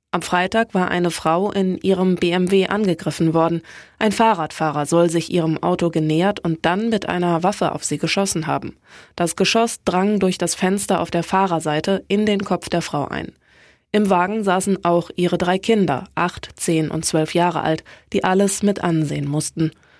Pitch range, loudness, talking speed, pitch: 165-195 Hz, -19 LUFS, 175 wpm, 175 Hz